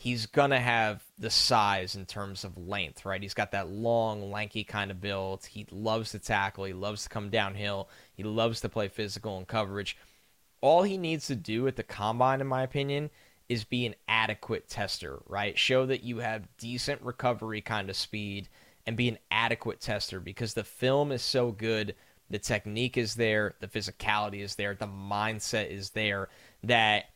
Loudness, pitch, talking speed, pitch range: -30 LUFS, 110 Hz, 190 wpm, 100-120 Hz